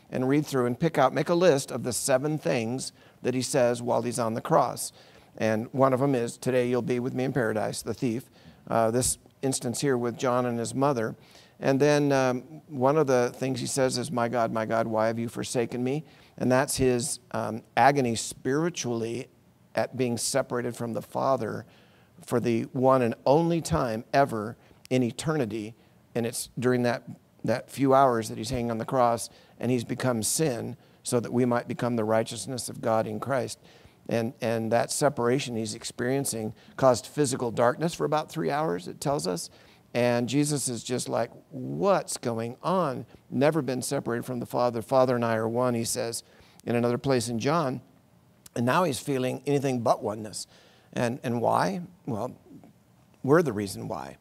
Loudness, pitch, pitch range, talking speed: -27 LUFS, 125 Hz, 115-135 Hz, 185 wpm